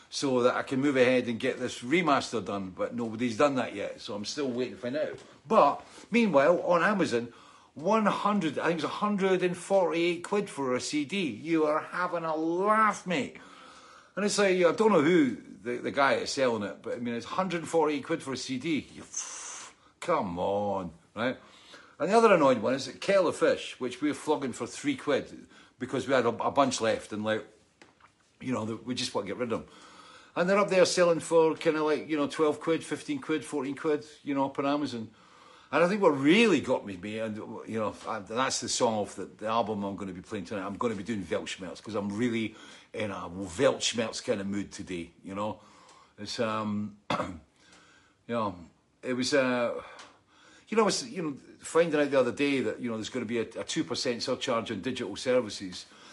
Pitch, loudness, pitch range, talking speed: 140 Hz, -29 LUFS, 115-175 Hz, 220 wpm